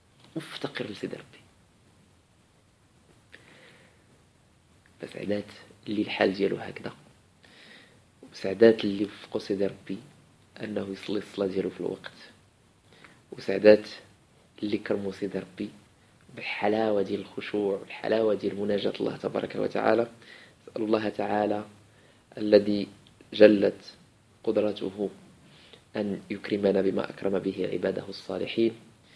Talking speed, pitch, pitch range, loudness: 90 wpm, 105 Hz, 100-110 Hz, -28 LUFS